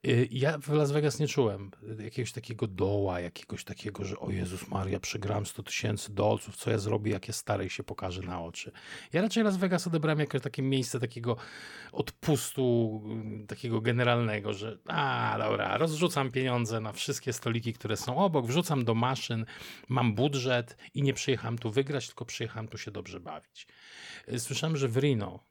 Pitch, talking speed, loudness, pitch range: 120 Hz, 170 wpm, -31 LUFS, 105-135 Hz